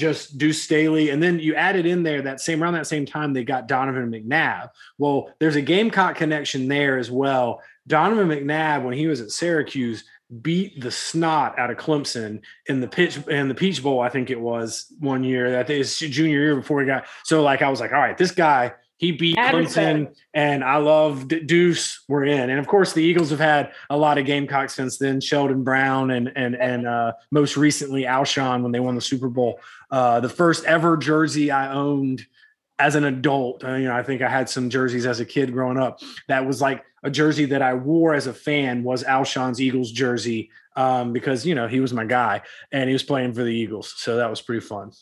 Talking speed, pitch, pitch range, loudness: 225 wpm, 140 Hz, 125-155 Hz, -21 LUFS